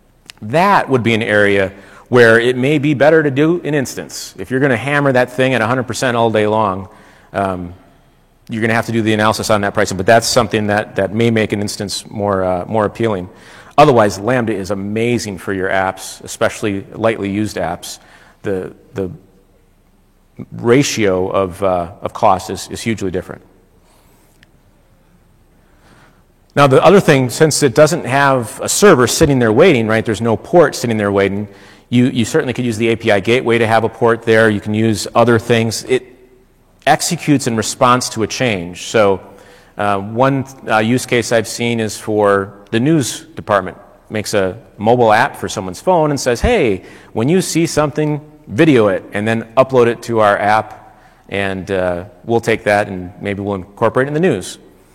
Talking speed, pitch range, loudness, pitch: 185 wpm, 100-125 Hz, -14 LUFS, 110 Hz